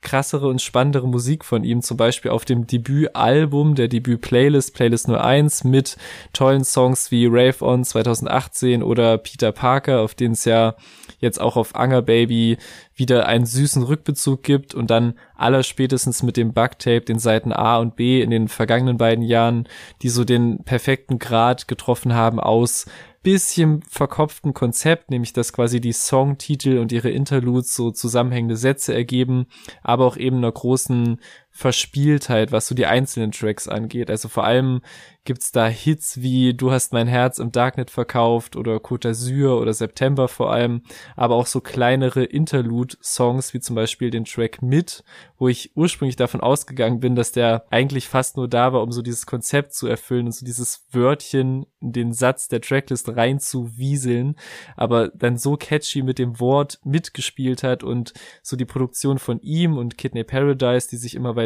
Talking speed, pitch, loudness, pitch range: 170 wpm, 125 Hz, -19 LUFS, 120-135 Hz